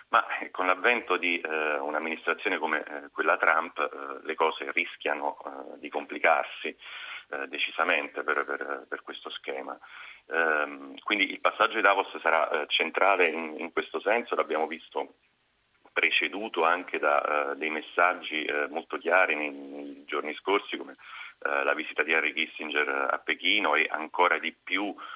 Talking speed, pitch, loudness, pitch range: 155 wpm, 80 Hz, -27 LUFS, 70-90 Hz